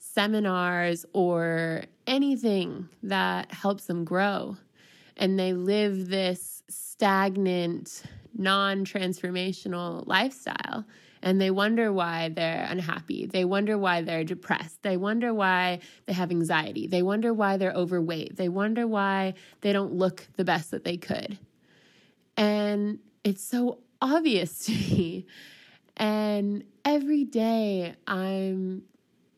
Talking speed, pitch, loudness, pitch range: 120 wpm, 190 Hz, -27 LUFS, 180-210 Hz